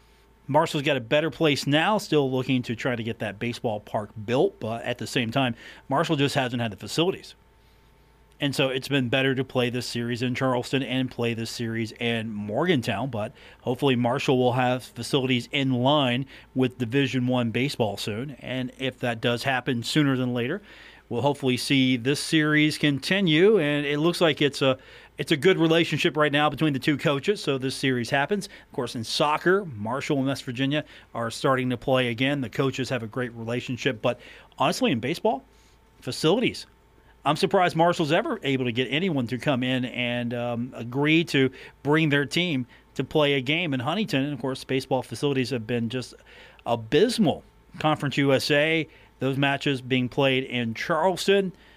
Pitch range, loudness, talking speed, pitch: 120-145 Hz, -25 LUFS, 180 wpm, 130 Hz